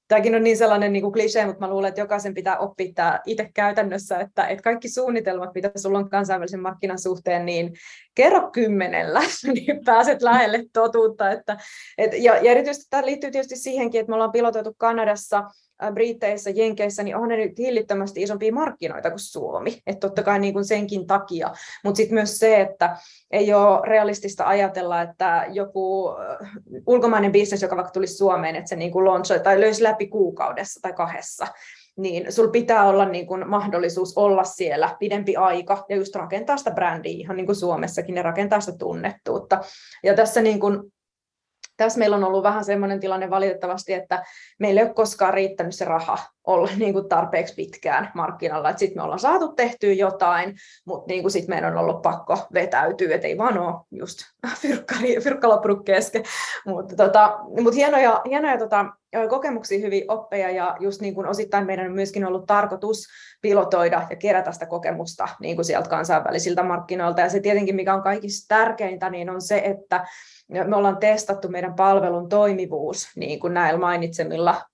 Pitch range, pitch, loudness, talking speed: 190-220 Hz, 200 Hz, -21 LUFS, 165 wpm